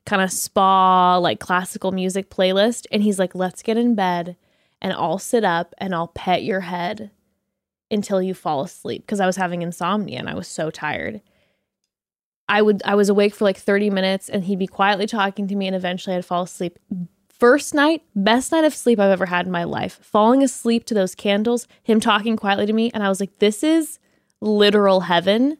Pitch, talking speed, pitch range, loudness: 200 Hz, 205 wpm, 185-215 Hz, -20 LUFS